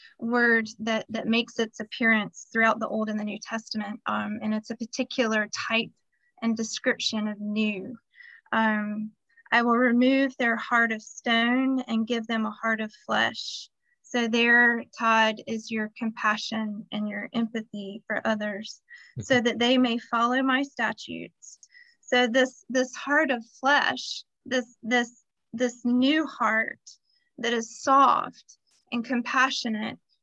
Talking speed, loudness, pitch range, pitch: 145 wpm, -25 LUFS, 220-255 Hz, 230 Hz